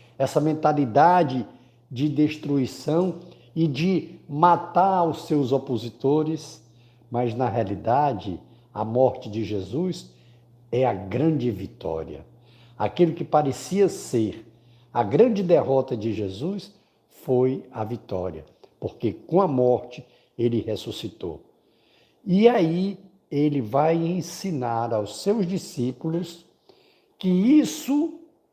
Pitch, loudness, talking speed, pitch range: 140 Hz, -24 LUFS, 105 wpm, 120-170 Hz